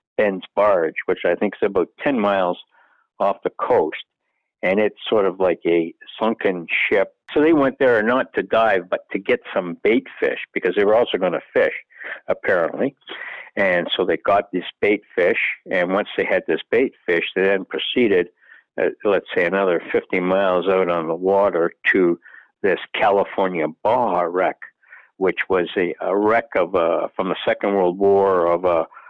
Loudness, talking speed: -20 LUFS, 180 wpm